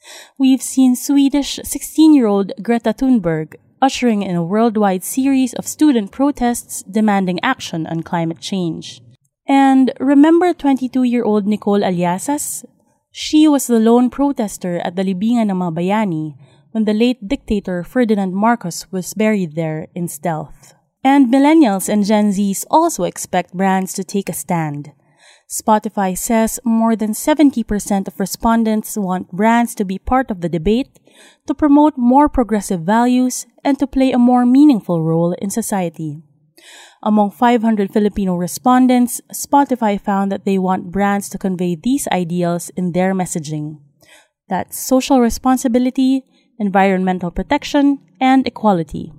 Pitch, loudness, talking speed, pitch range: 215 Hz, -16 LUFS, 135 wpm, 185-260 Hz